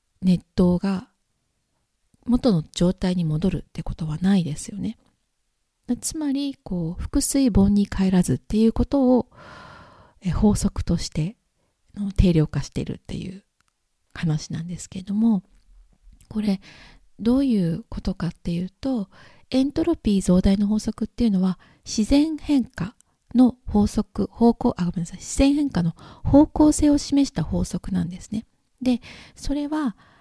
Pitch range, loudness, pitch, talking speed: 180-250 Hz, -23 LUFS, 200 Hz, 245 characters per minute